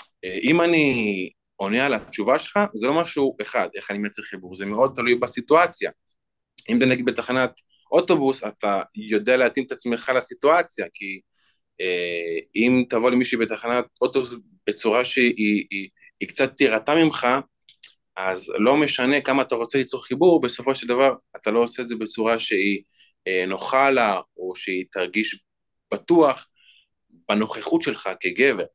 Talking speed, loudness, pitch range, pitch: 150 wpm, -22 LUFS, 105-135 Hz, 125 Hz